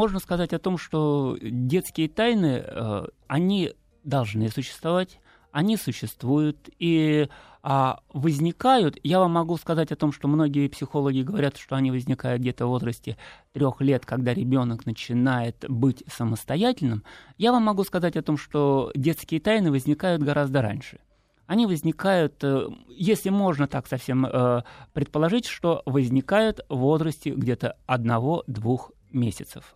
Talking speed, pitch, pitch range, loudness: 125 wpm, 145 Hz, 130-170 Hz, -25 LUFS